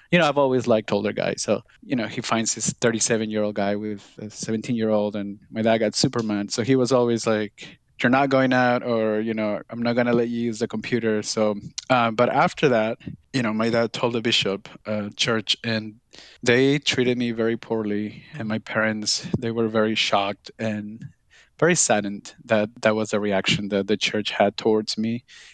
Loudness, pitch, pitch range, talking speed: -23 LUFS, 115 Hz, 105-120 Hz, 210 wpm